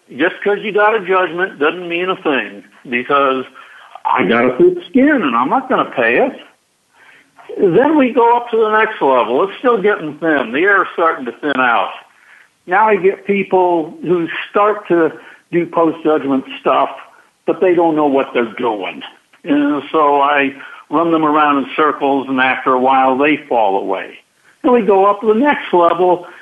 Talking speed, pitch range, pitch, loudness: 190 wpm, 145-215 Hz, 175 Hz, -14 LUFS